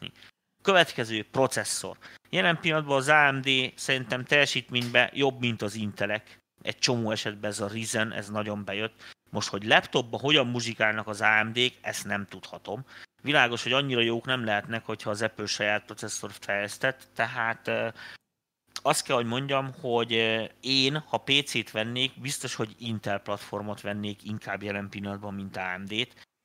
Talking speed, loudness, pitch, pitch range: 145 wpm, -27 LUFS, 115 Hz, 105-130 Hz